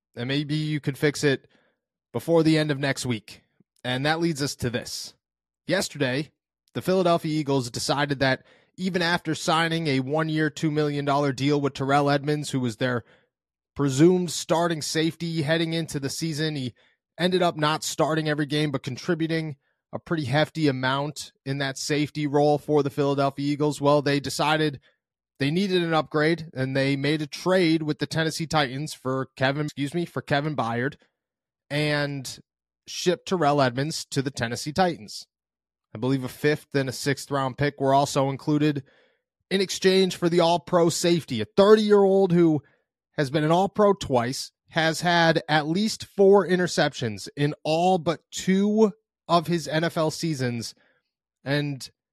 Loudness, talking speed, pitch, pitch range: -24 LUFS, 165 wpm, 150 Hz, 135-165 Hz